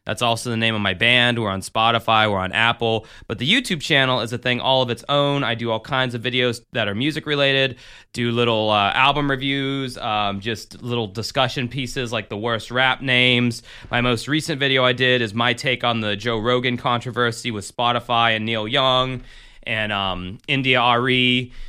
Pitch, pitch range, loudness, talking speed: 120 Hz, 115-130 Hz, -19 LUFS, 200 wpm